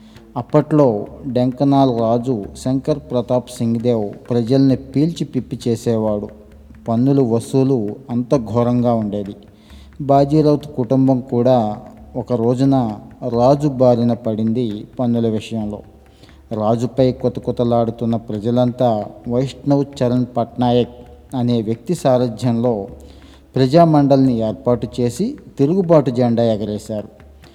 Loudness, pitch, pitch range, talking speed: -17 LUFS, 120 Hz, 110-135 Hz, 90 wpm